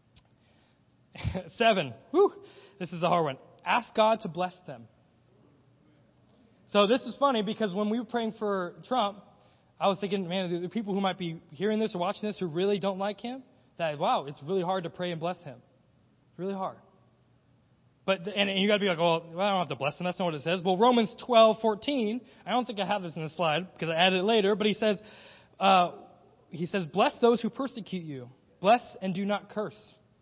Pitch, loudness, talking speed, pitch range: 190 Hz, -28 LUFS, 215 wpm, 165-215 Hz